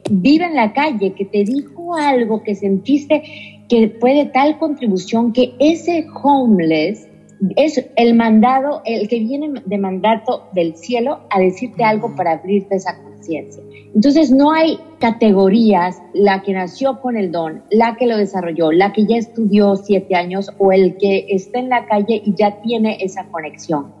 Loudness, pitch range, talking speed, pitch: -15 LUFS, 195-250 Hz, 165 wpm, 215 Hz